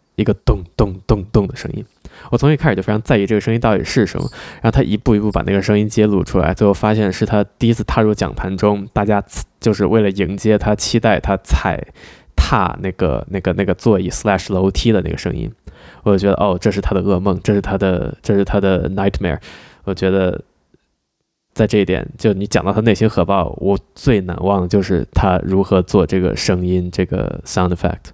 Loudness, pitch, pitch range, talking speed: -16 LUFS, 100 Hz, 95-105 Hz, 355 characters per minute